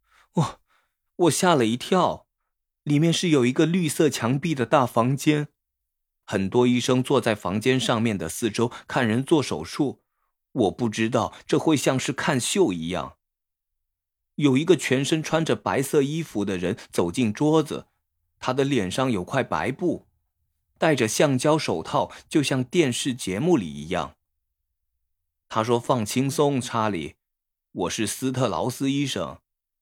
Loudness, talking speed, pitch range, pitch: -23 LUFS, 210 characters per minute, 95-145 Hz, 125 Hz